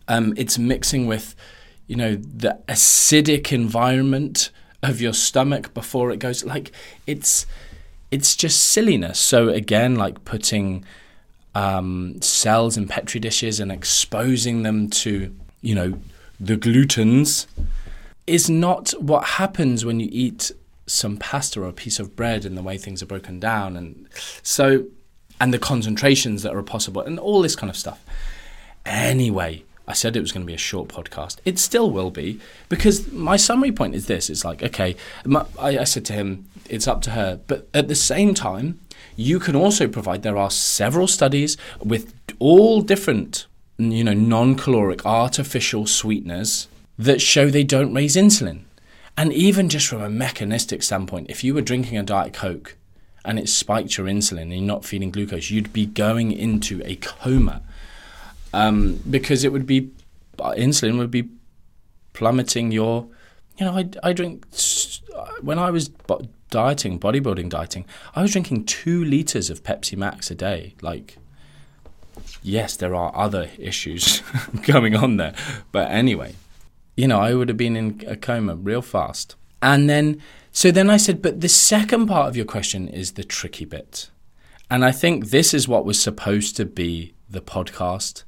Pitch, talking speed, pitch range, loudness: 115 Hz, 165 wpm, 95-135 Hz, -19 LUFS